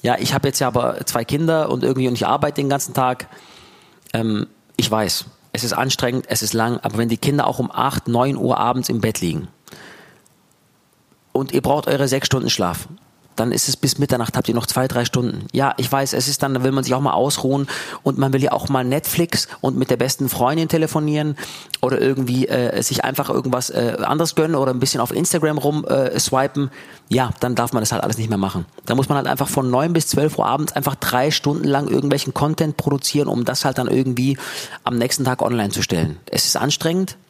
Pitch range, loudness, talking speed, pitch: 120-145 Hz, -19 LUFS, 225 wpm, 130 Hz